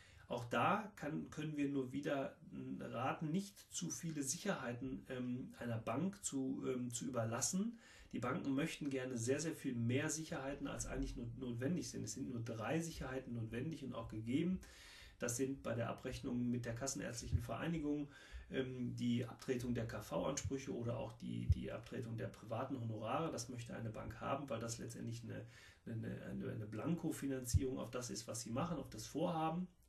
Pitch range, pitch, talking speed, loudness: 115-145 Hz, 130 Hz, 170 wpm, -43 LUFS